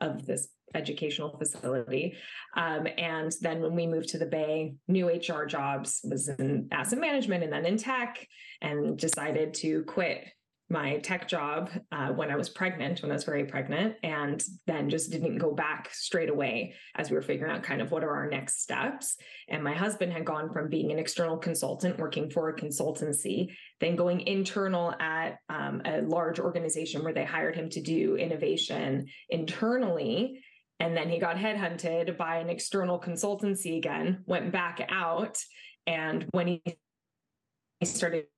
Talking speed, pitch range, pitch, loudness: 170 wpm, 155-180 Hz, 165 Hz, -31 LUFS